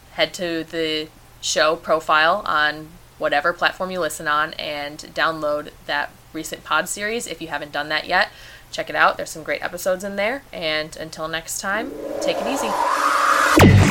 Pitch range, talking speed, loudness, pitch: 155-170 Hz, 170 wpm, -21 LUFS, 155 Hz